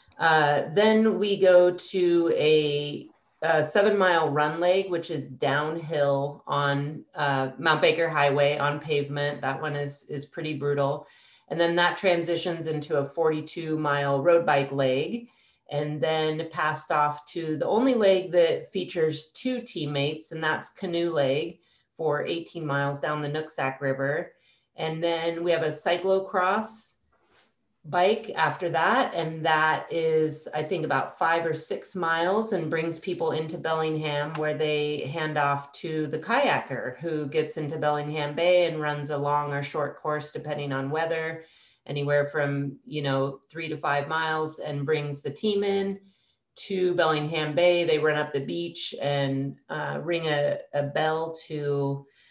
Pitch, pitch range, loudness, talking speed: 155 Hz, 145-170 Hz, -26 LUFS, 155 wpm